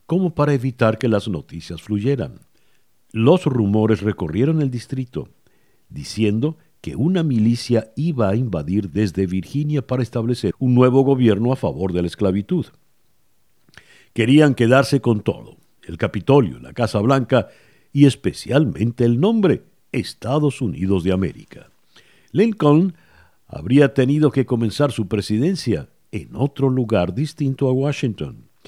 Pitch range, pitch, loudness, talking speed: 105-140 Hz, 125 Hz, -19 LUFS, 130 wpm